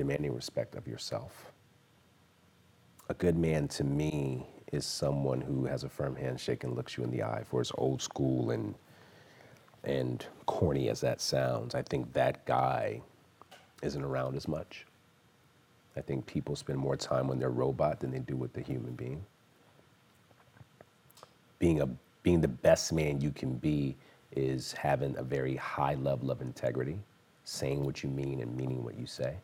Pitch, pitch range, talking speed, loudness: 65 Hz, 65-70 Hz, 165 wpm, -34 LUFS